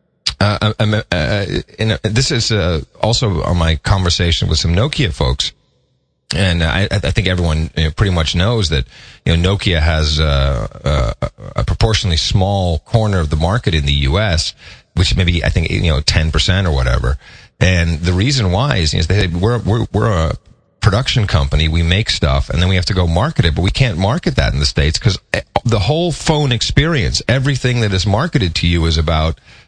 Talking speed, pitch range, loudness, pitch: 200 wpm, 80-110 Hz, -15 LUFS, 95 Hz